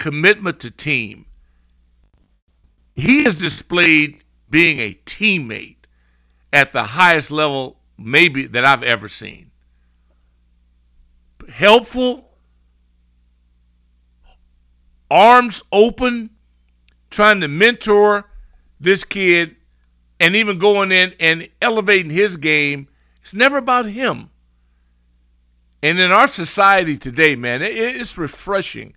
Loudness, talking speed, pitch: -14 LUFS, 95 wpm, 140 Hz